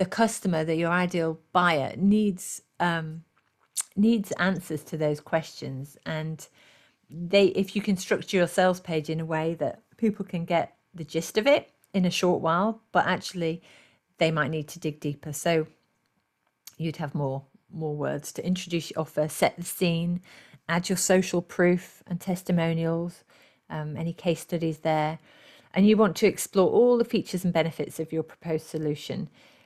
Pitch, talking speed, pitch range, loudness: 170 Hz, 170 wpm, 160-185 Hz, -27 LUFS